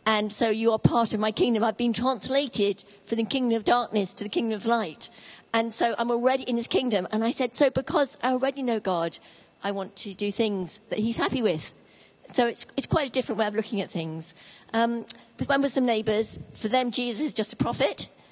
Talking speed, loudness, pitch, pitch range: 240 wpm, -26 LUFS, 230 Hz, 210-250 Hz